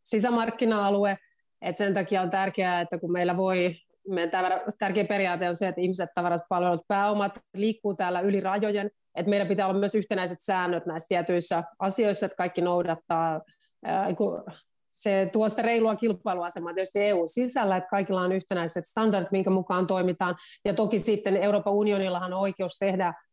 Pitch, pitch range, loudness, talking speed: 195 Hz, 180-205 Hz, -27 LUFS, 150 wpm